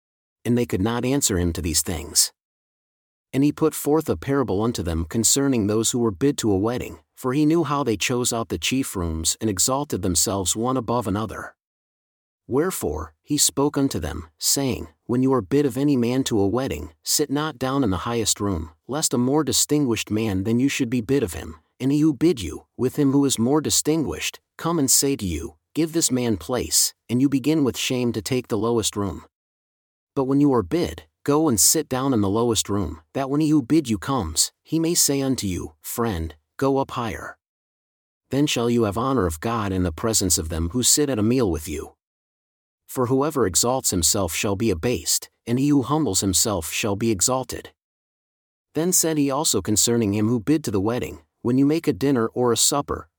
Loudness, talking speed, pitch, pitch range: -22 LUFS, 210 wpm, 115 Hz, 95-140 Hz